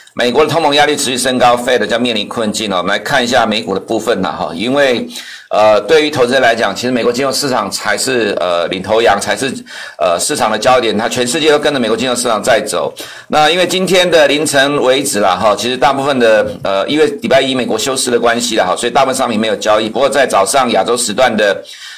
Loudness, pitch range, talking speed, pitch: -12 LUFS, 110-150 Hz, 365 characters per minute, 130 Hz